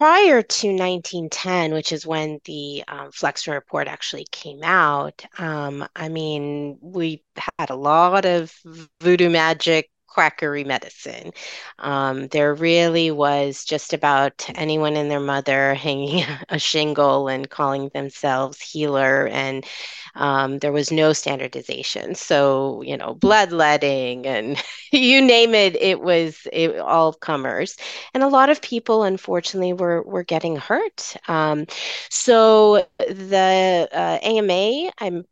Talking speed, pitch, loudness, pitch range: 130 wpm, 160 Hz, -19 LUFS, 145-185 Hz